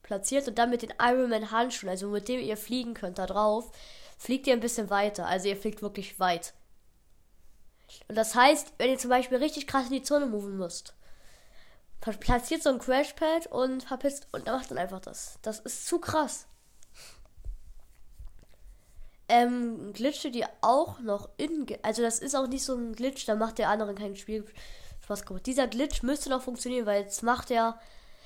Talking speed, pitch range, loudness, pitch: 180 wpm, 200-260 Hz, -29 LUFS, 230 Hz